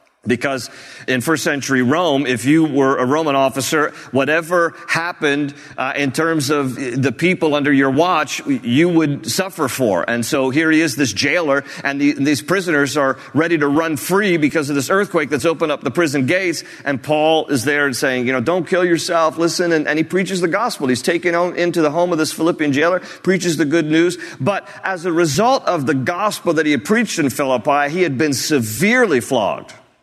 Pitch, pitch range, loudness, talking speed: 155 Hz, 140-175 Hz, -17 LUFS, 205 wpm